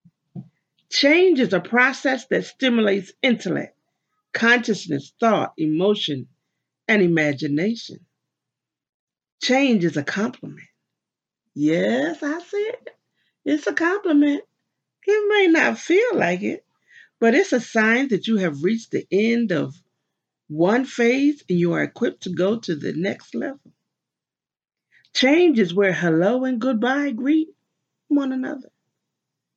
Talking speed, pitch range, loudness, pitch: 125 wpm, 180-290 Hz, -20 LUFS, 235 Hz